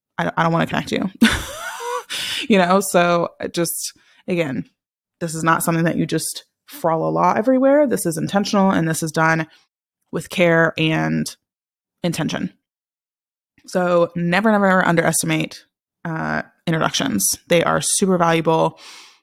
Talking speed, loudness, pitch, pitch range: 135 wpm, -19 LUFS, 170 Hz, 160-205 Hz